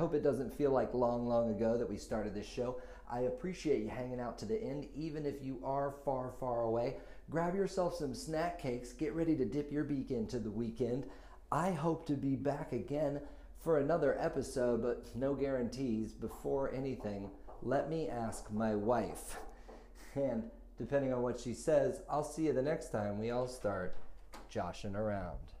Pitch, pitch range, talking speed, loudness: 125 Hz, 115-145 Hz, 185 wpm, -37 LUFS